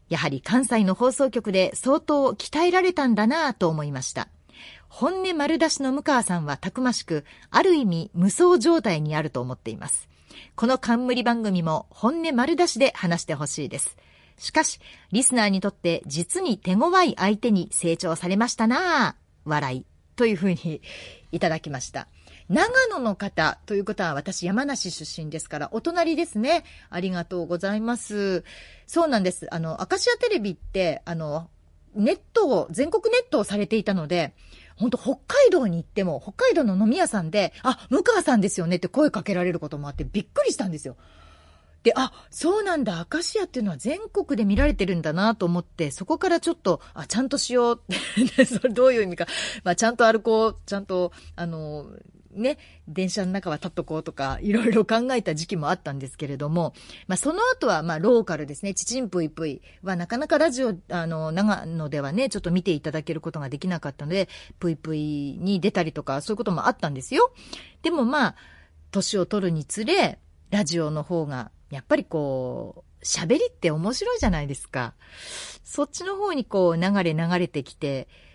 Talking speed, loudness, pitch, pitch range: 375 characters per minute, -24 LUFS, 195 Hz, 165-255 Hz